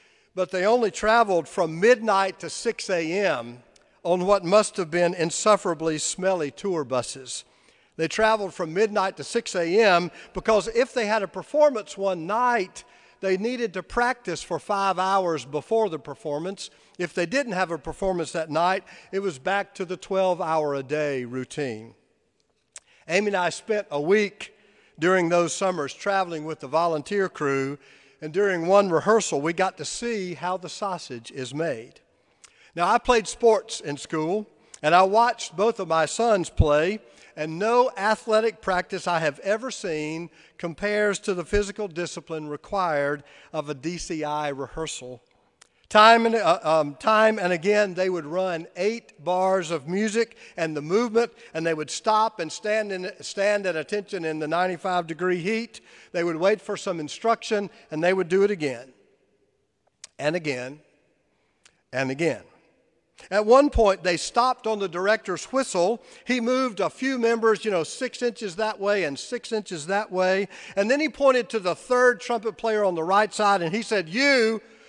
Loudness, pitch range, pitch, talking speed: -24 LUFS, 165-215 Hz, 190 Hz, 170 wpm